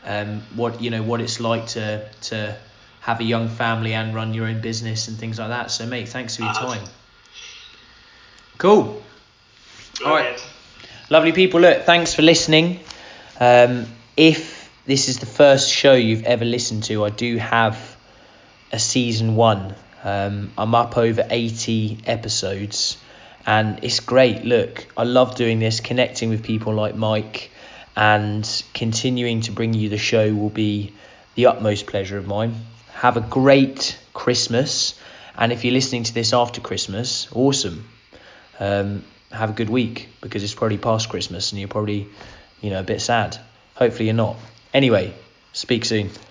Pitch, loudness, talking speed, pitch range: 115 Hz, -19 LUFS, 160 wpm, 105-120 Hz